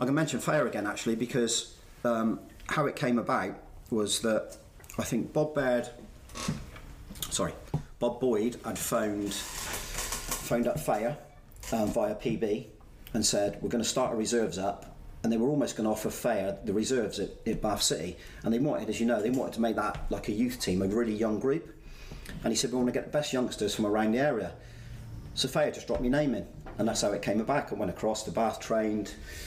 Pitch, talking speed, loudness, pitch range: 115 Hz, 205 wpm, -30 LUFS, 105-120 Hz